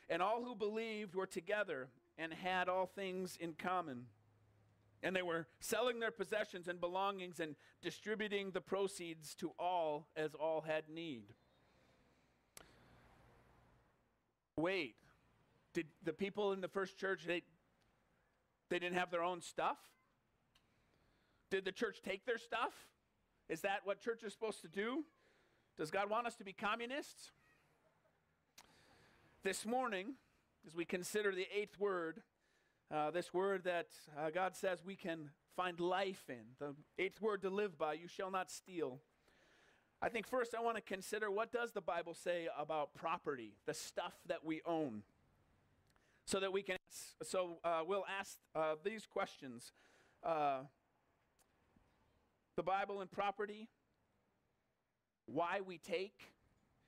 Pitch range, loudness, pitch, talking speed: 165-200 Hz, -43 LUFS, 185 Hz, 140 wpm